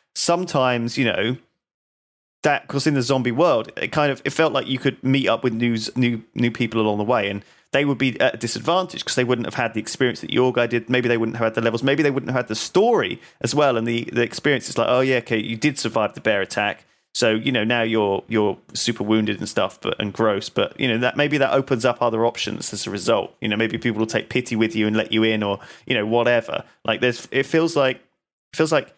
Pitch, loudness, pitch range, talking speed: 120 Hz, -21 LUFS, 110-130 Hz, 265 wpm